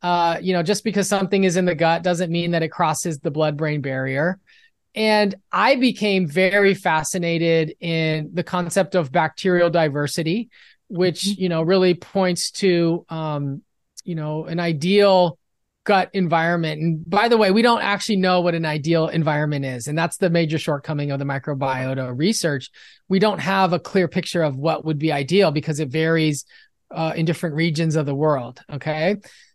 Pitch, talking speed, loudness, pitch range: 170 Hz, 175 wpm, -20 LUFS, 155-190 Hz